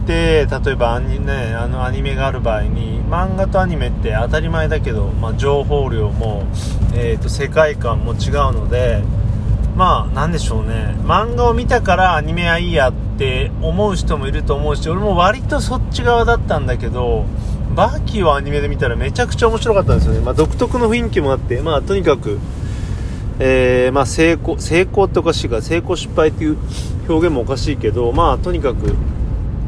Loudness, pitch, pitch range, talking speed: -17 LUFS, 110 Hz, 105-130 Hz, 360 characters per minute